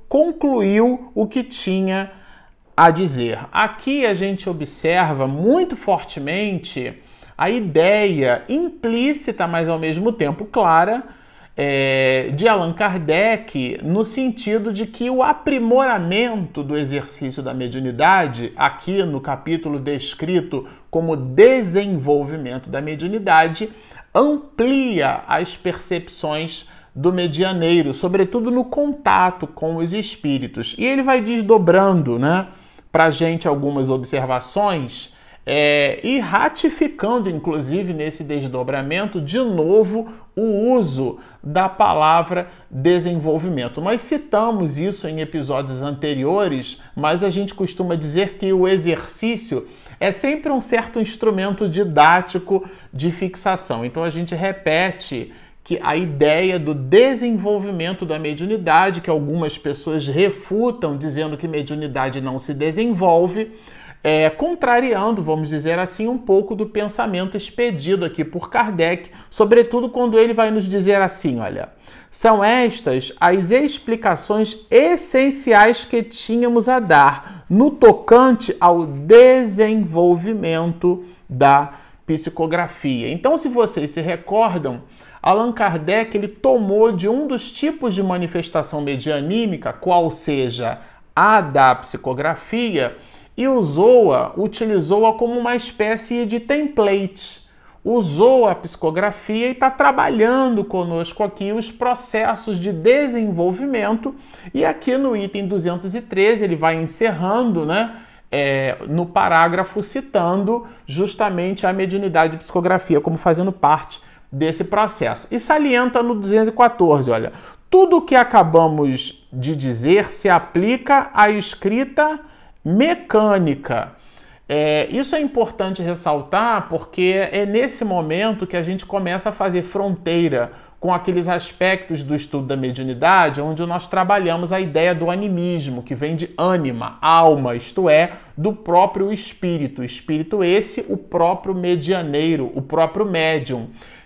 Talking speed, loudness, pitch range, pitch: 120 wpm, -18 LUFS, 155-225 Hz, 185 Hz